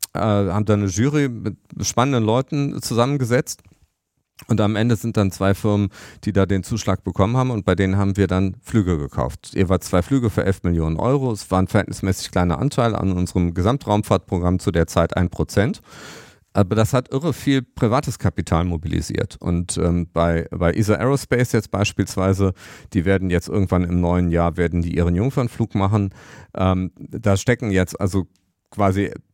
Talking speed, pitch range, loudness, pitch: 170 wpm, 90-115 Hz, -20 LUFS, 100 Hz